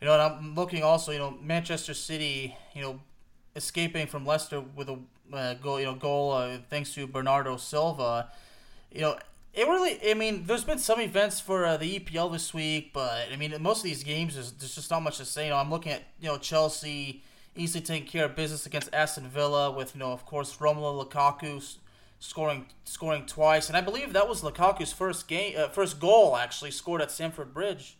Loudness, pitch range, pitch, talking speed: -29 LUFS, 140-165 Hz, 150 Hz, 215 wpm